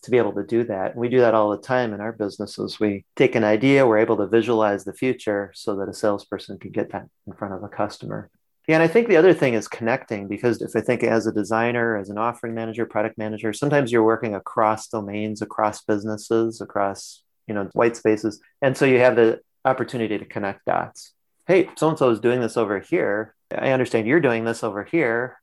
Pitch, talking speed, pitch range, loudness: 110 Hz, 225 wpm, 105-120 Hz, -22 LUFS